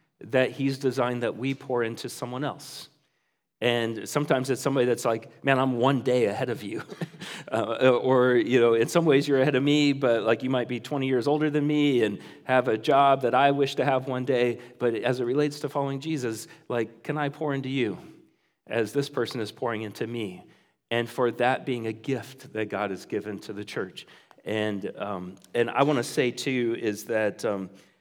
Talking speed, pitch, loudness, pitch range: 210 wpm, 125 Hz, -26 LUFS, 115-140 Hz